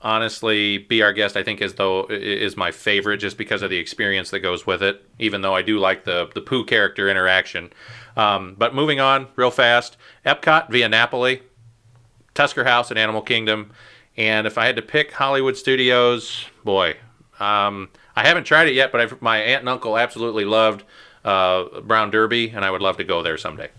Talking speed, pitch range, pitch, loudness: 195 wpm, 105-120 Hz, 110 Hz, -19 LUFS